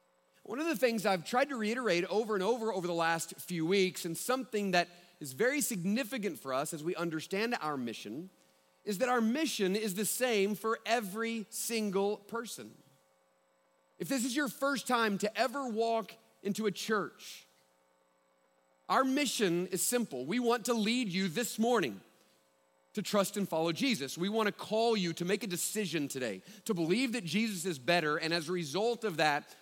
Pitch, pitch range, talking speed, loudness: 200 Hz, 165-230 Hz, 180 wpm, -33 LUFS